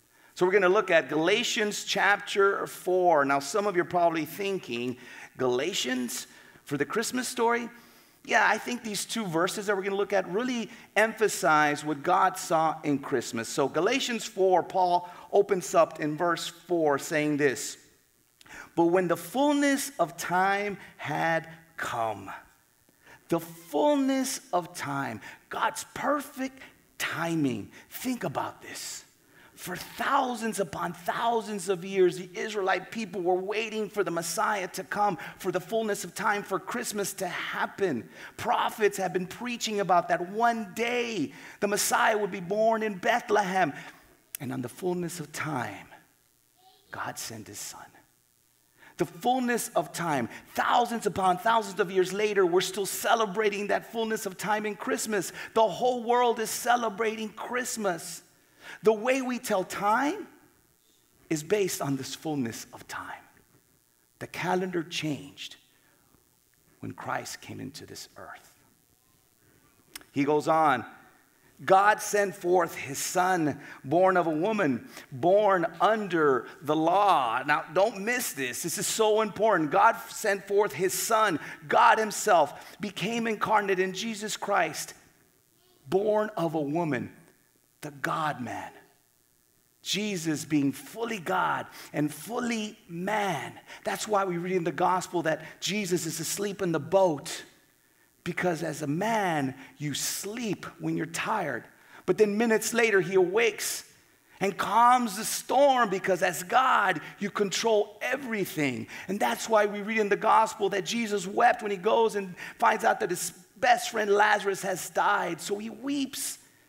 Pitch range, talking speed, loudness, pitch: 170-220 Hz, 145 wpm, -27 LUFS, 195 Hz